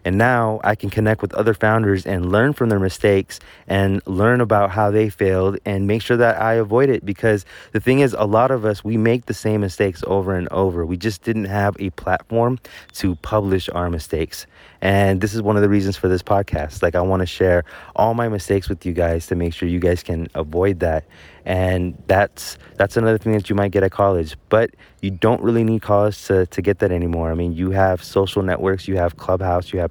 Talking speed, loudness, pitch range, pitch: 230 wpm, -19 LUFS, 90-110 Hz, 100 Hz